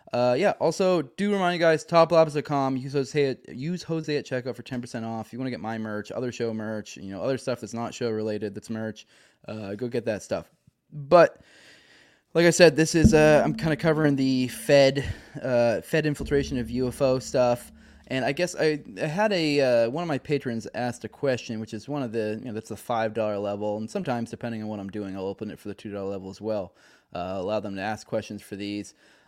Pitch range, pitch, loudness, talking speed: 110-145 Hz, 125 Hz, -25 LUFS, 230 wpm